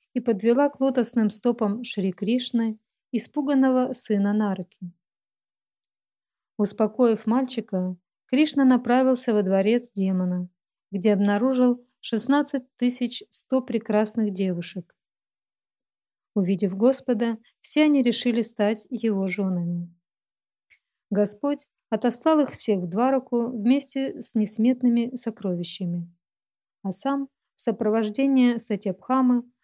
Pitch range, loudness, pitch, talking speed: 200-255 Hz, -24 LUFS, 230 Hz, 95 wpm